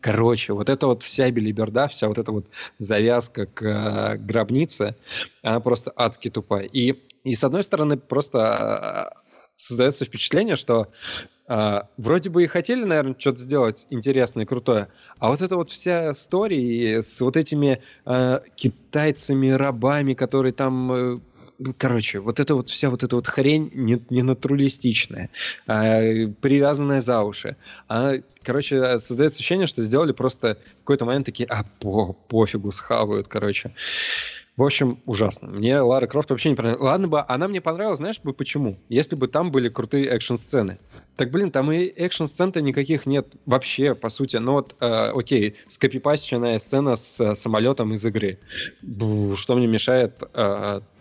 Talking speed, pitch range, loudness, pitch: 160 wpm, 115-140 Hz, -22 LUFS, 130 Hz